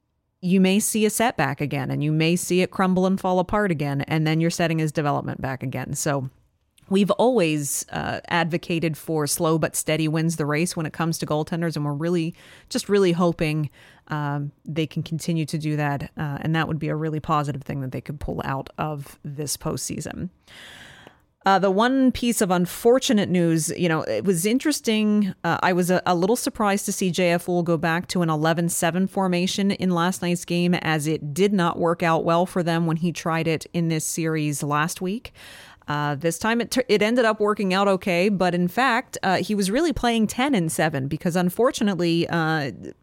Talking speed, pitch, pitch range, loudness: 205 wpm, 170 Hz, 155-190 Hz, -23 LUFS